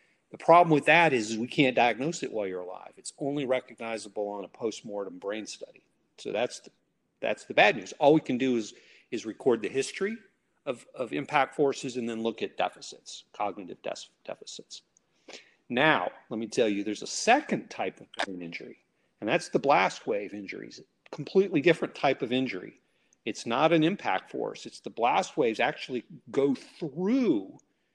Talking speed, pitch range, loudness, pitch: 180 wpm, 110-155 Hz, -28 LUFS, 130 Hz